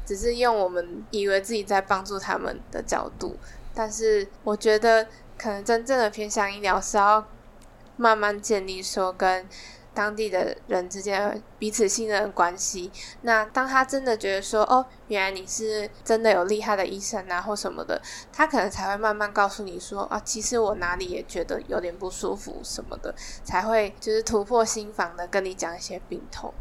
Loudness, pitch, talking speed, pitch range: -25 LUFS, 210 Hz, 275 characters per minute, 195-220 Hz